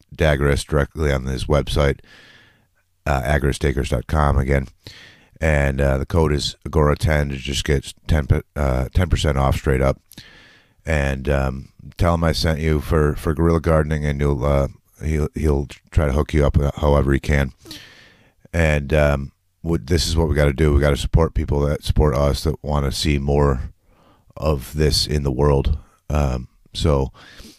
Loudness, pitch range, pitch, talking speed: -20 LUFS, 70-80 Hz, 75 Hz, 170 wpm